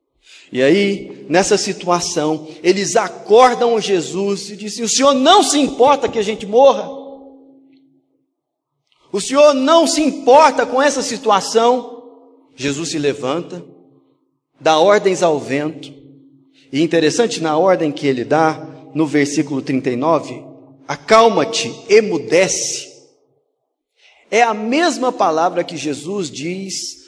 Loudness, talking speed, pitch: -15 LUFS, 115 wpm, 205 Hz